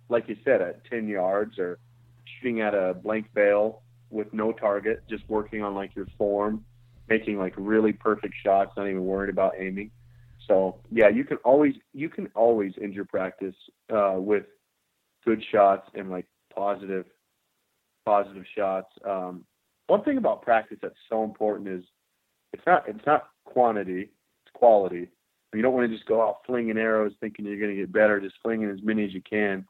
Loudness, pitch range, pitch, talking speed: -26 LUFS, 95-115 Hz, 105 Hz, 180 wpm